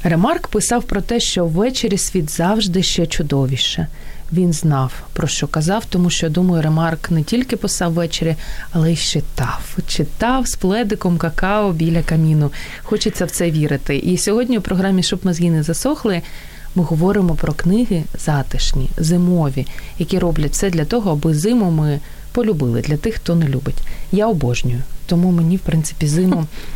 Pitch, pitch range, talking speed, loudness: 170 Hz, 155-200 Hz, 160 wpm, -18 LUFS